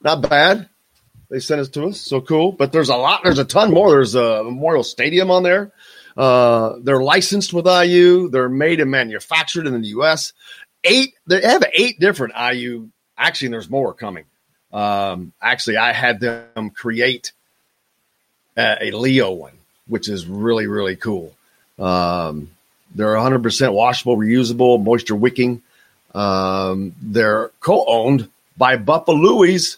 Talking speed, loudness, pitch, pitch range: 145 wpm, -16 LUFS, 125 Hz, 110-160 Hz